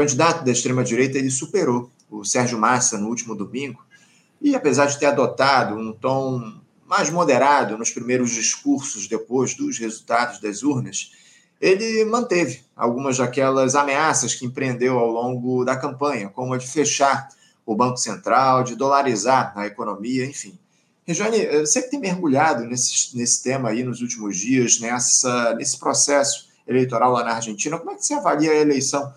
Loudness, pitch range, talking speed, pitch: -20 LUFS, 120-145 Hz, 160 wpm, 130 Hz